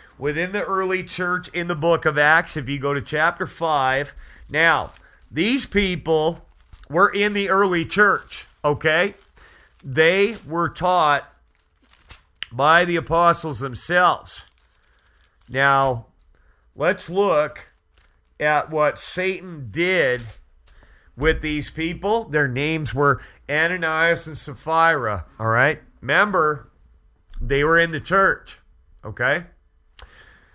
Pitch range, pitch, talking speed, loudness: 125-175 Hz, 155 Hz, 110 wpm, -20 LUFS